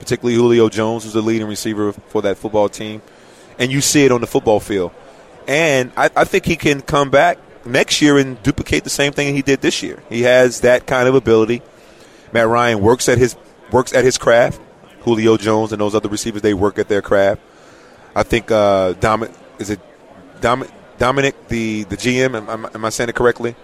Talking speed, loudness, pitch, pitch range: 205 wpm, -16 LUFS, 115 Hz, 110-130 Hz